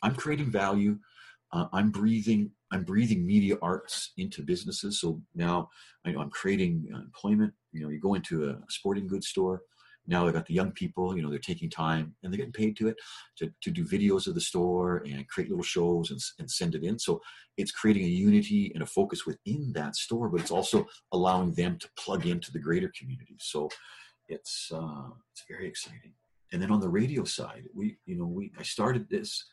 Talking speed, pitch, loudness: 205 wpm, 110 Hz, -30 LUFS